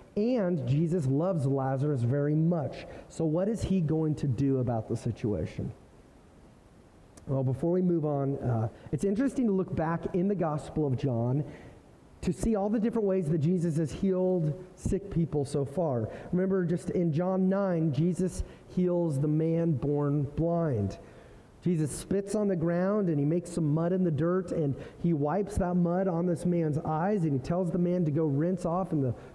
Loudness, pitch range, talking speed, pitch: -29 LUFS, 145-185 Hz, 185 wpm, 165 Hz